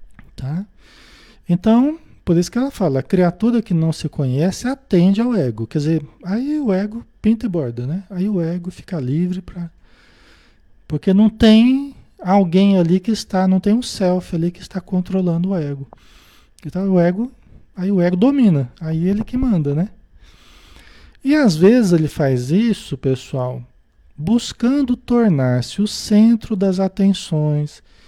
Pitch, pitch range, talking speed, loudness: 185 Hz, 165-220 Hz, 155 wpm, -18 LUFS